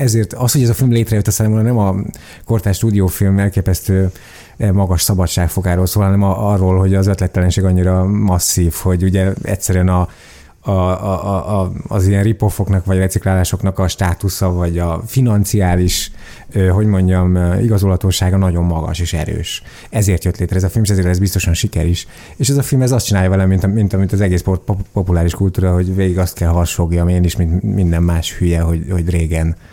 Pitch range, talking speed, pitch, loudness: 90-100 Hz, 190 wpm, 95 Hz, -15 LUFS